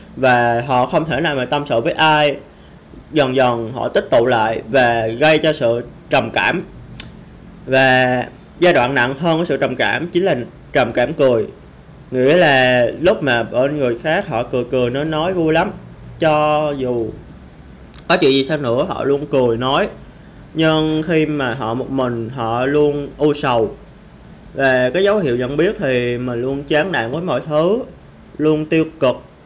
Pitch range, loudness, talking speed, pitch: 120-155 Hz, -16 LUFS, 180 wpm, 135 Hz